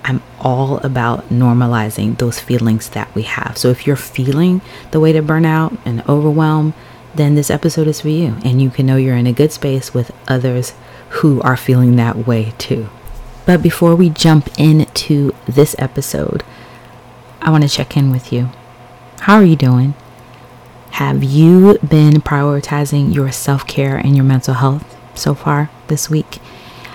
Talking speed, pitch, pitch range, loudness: 170 wpm, 135 Hz, 125-150 Hz, -13 LUFS